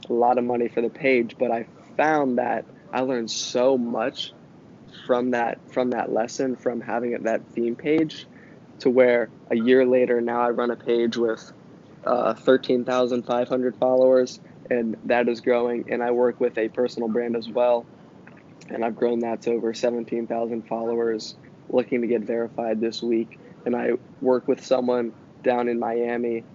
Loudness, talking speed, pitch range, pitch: -24 LUFS, 170 wpm, 115-125 Hz, 120 Hz